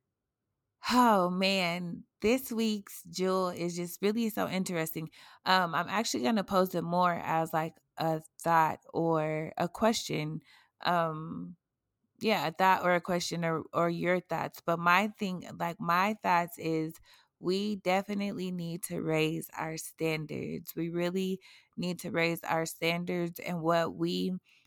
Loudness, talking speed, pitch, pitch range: -31 LUFS, 145 wpm, 175 Hz, 160-185 Hz